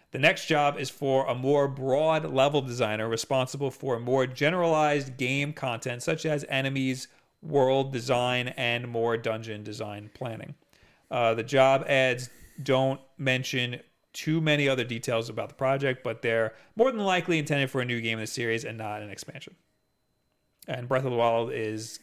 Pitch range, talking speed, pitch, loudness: 115-140 Hz, 170 wpm, 130 Hz, -27 LUFS